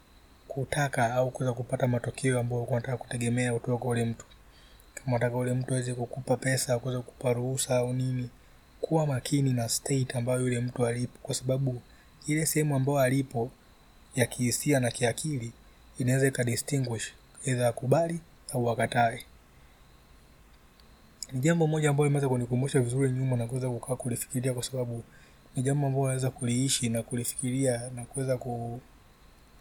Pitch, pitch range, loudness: 125 Hz, 120-130 Hz, -29 LUFS